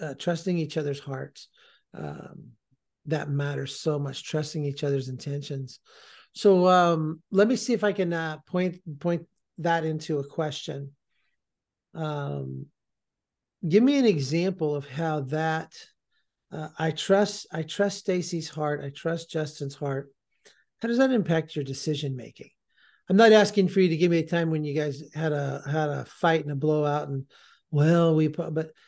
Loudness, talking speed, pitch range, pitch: -26 LUFS, 165 wpm, 145-175 Hz, 155 Hz